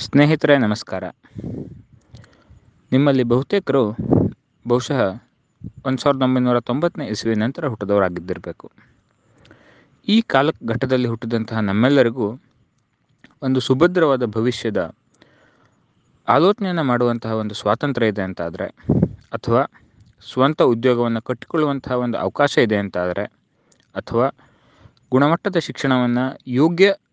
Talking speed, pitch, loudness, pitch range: 80 wpm, 125 Hz, -19 LUFS, 115-145 Hz